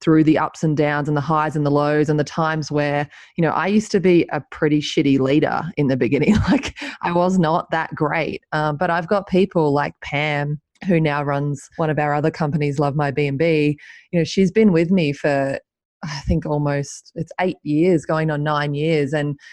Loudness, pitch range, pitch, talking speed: -19 LUFS, 145-165 Hz, 150 Hz, 215 wpm